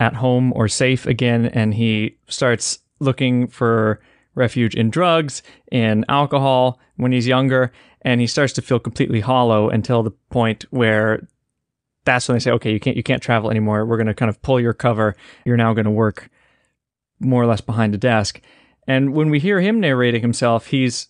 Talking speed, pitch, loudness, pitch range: 185 wpm, 120 Hz, -18 LUFS, 115-130 Hz